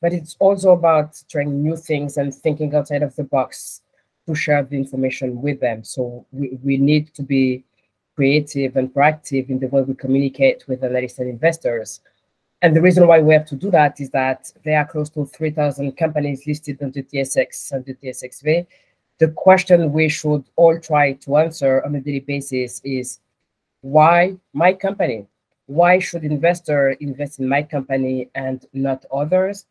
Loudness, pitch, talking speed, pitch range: -18 LUFS, 145 Hz, 175 wpm, 135-155 Hz